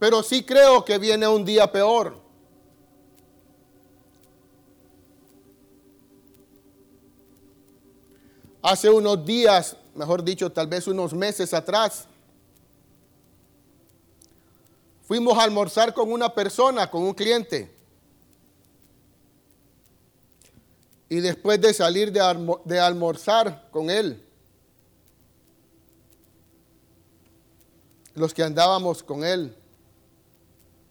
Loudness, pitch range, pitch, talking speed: -21 LUFS, 135-215 Hz, 180 Hz, 80 wpm